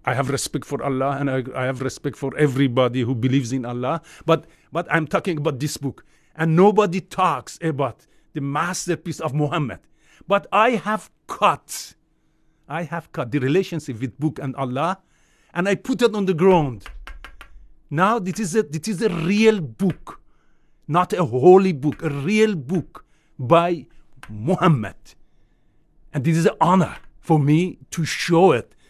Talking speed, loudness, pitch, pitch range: 165 wpm, -21 LUFS, 160 Hz, 140-185 Hz